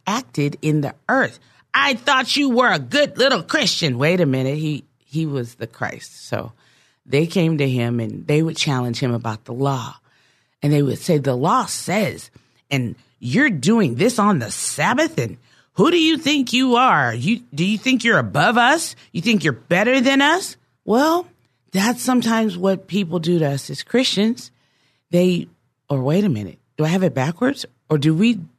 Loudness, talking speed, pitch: -19 LUFS, 190 wpm, 175 Hz